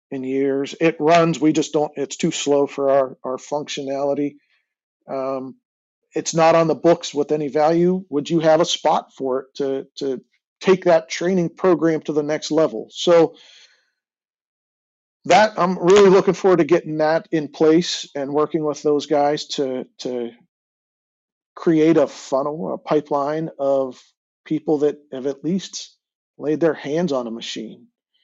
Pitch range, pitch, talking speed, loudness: 140-165 Hz, 150 Hz, 160 wpm, -19 LUFS